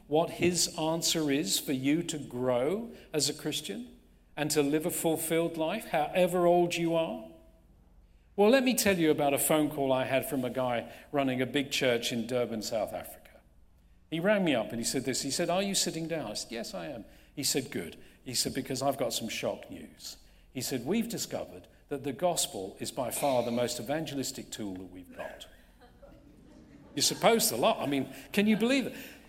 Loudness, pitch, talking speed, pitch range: -30 LUFS, 150 Hz, 205 wpm, 130-175 Hz